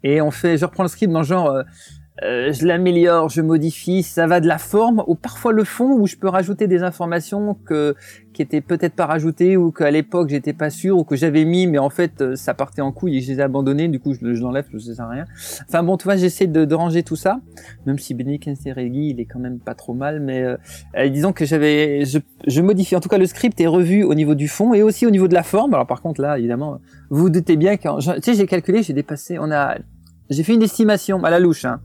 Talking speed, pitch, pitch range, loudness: 260 wpm, 160 Hz, 140-185 Hz, -18 LUFS